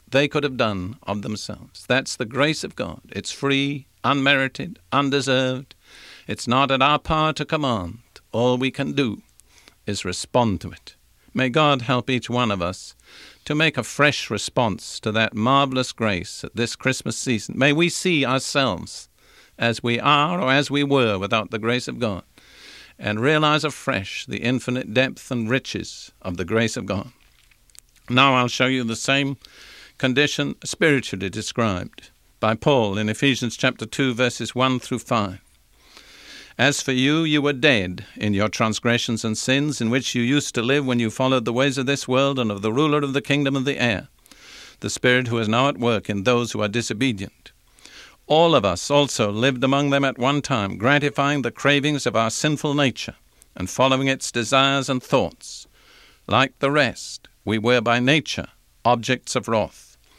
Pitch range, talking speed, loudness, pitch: 110-140 Hz, 175 wpm, -21 LUFS, 125 Hz